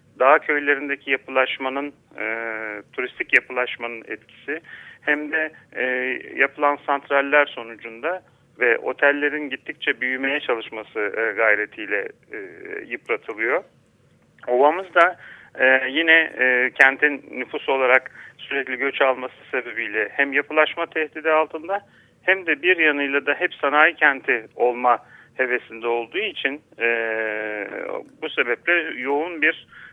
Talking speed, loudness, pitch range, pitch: 110 wpm, -21 LUFS, 125-155 Hz, 140 Hz